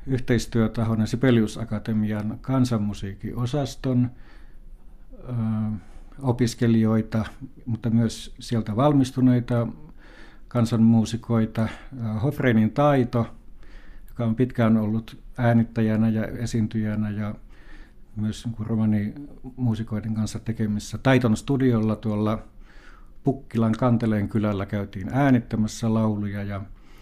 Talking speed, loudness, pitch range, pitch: 80 wpm, -24 LUFS, 110-125 Hz, 115 Hz